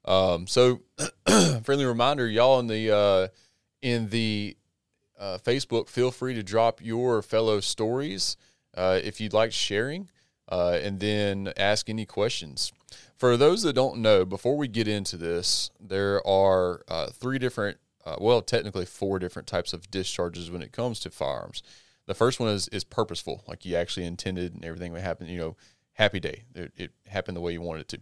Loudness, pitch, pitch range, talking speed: -26 LUFS, 105 Hz, 90-115 Hz, 180 wpm